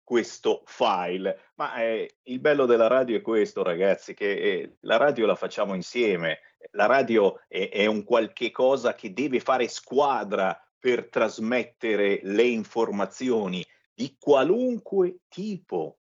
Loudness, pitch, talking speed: -25 LUFS, 255 Hz, 135 wpm